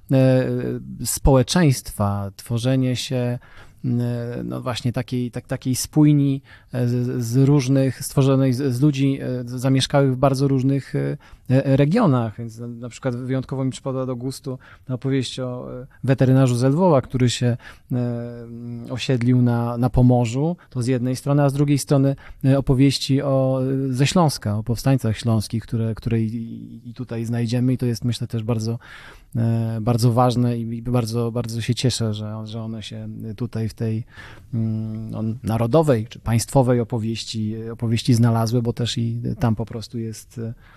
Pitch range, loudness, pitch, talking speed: 115-130 Hz, -21 LUFS, 125 Hz, 135 wpm